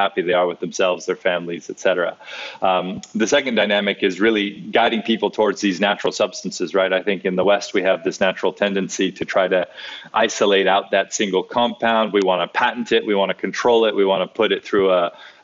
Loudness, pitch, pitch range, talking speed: -19 LUFS, 100 Hz, 95-115 Hz, 220 wpm